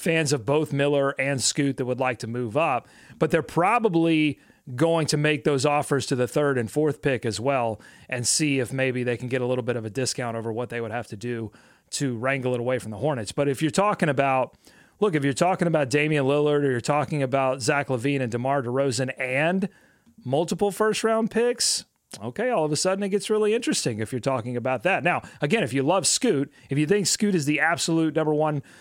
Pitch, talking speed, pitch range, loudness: 140 Hz, 230 wpm, 130-165 Hz, -24 LUFS